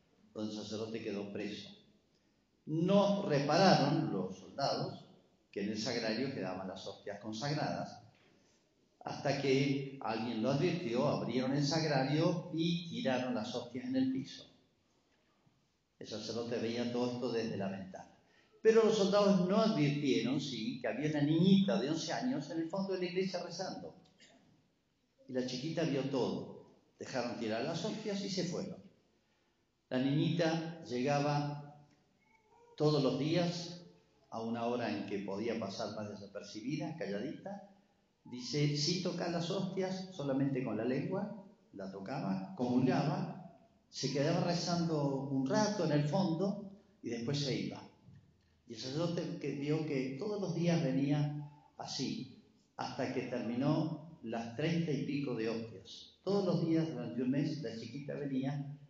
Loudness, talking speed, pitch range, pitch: -36 LUFS, 145 wpm, 125-175 Hz, 145 Hz